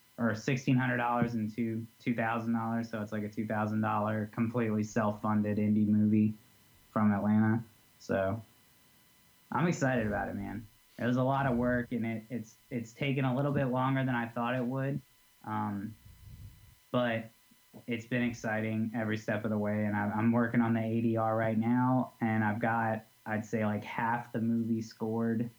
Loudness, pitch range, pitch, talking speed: -32 LUFS, 110-120 Hz, 115 Hz, 180 wpm